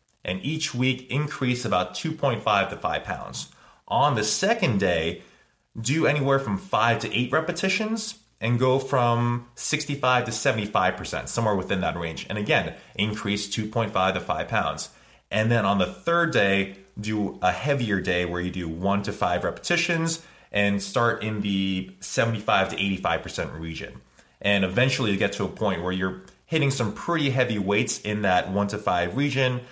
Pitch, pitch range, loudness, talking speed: 110 Hz, 100-135 Hz, -25 LUFS, 165 wpm